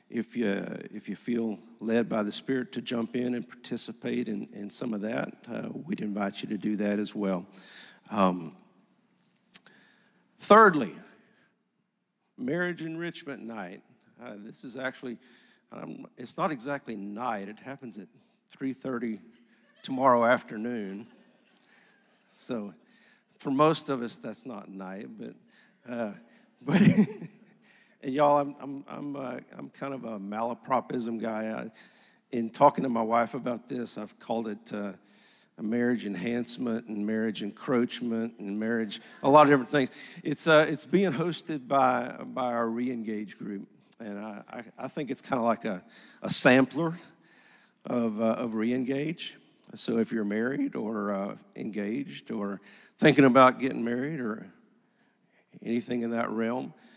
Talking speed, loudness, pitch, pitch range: 145 wpm, -28 LUFS, 120 Hz, 110-140 Hz